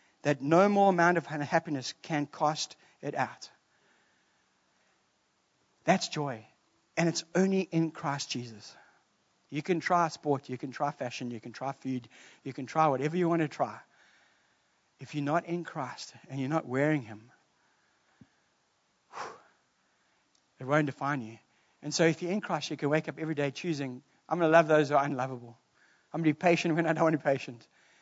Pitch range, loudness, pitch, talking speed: 135-165 Hz, -30 LUFS, 150 Hz, 180 wpm